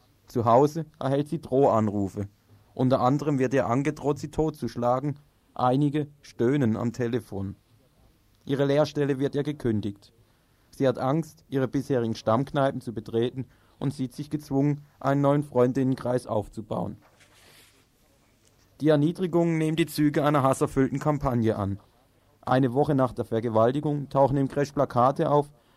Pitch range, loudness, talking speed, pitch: 115-145 Hz, -26 LUFS, 130 wpm, 130 Hz